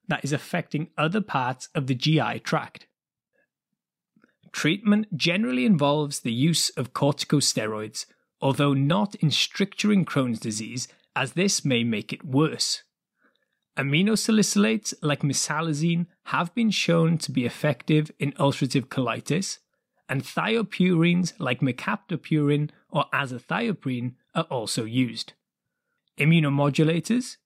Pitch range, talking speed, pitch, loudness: 135-180 Hz, 110 wpm, 150 Hz, -25 LUFS